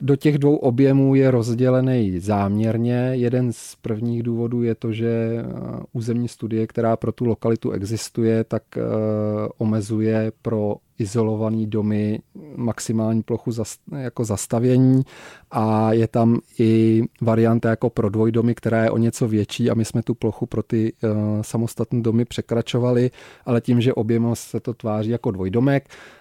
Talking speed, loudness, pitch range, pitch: 140 wpm, -21 LUFS, 110-120 Hz, 115 Hz